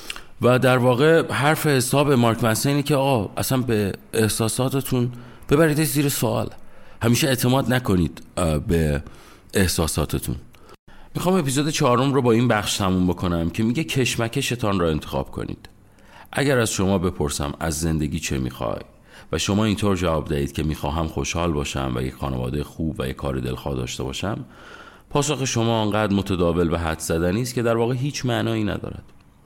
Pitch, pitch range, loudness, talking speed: 105 Hz, 80-125 Hz, -22 LUFS, 155 wpm